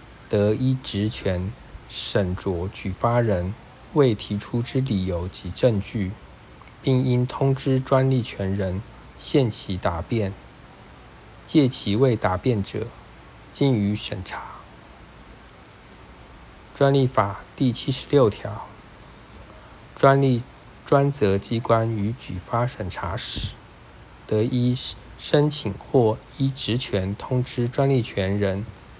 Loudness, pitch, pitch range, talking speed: -24 LUFS, 115 Hz, 100-130 Hz, 155 characters per minute